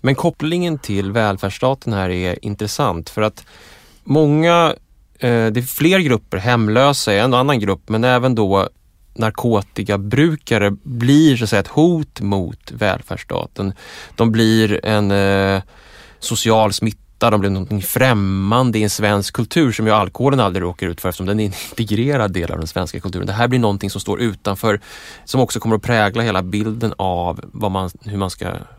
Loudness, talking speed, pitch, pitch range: -17 LUFS, 170 wpm, 110 Hz, 100-125 Hz